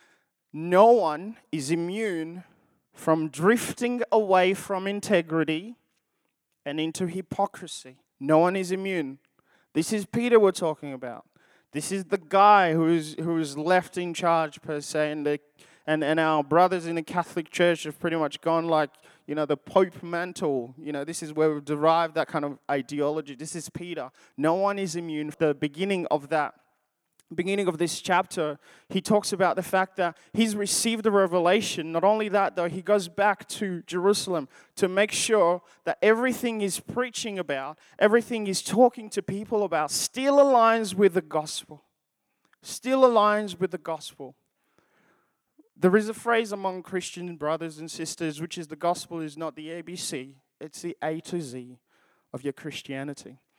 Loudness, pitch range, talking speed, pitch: -25 LUFS, 155-200 Hz, 165 wpm, 175 Hz